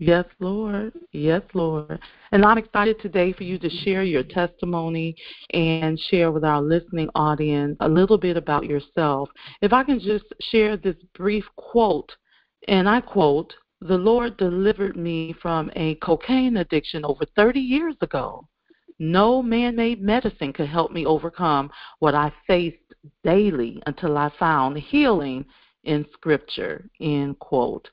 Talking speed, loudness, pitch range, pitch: 145 wpm, -22 LUFS, 155-210 Hz, 175 Hz